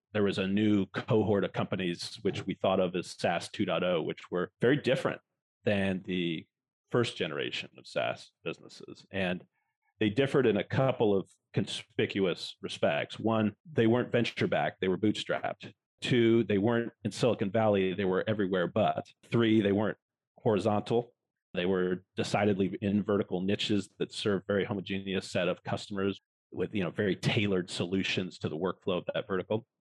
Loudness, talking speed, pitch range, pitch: -31 LUFS, 160 wpm, 95-115 Hz, 105 Hz